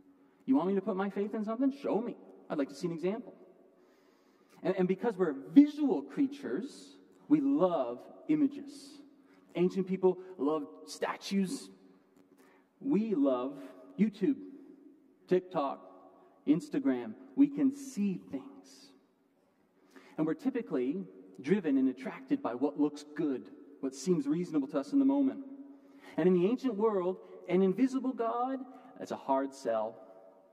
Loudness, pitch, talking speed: -32 LUFS, 185 Hz, 135 wpm